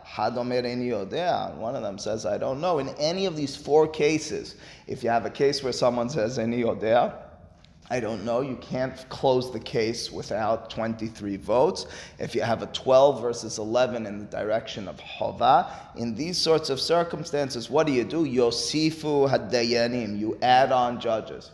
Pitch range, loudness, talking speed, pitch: 115-145 Hz, -25 LUFS, 160 wpm, 125 Hz